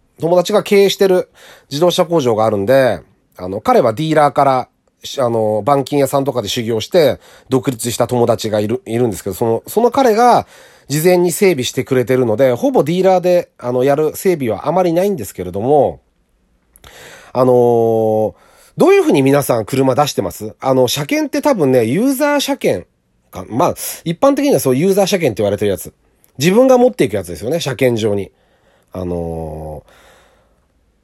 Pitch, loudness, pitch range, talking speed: 135 Hz, -14 LUFS, 115-180 Hz, 360 characters per minute